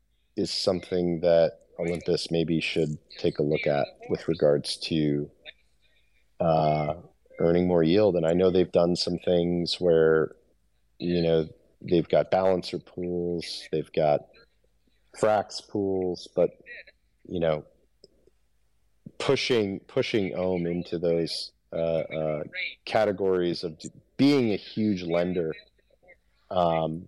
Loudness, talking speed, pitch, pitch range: -26 LUFS, 115 wpm, 85 Hz, 80-90 Hz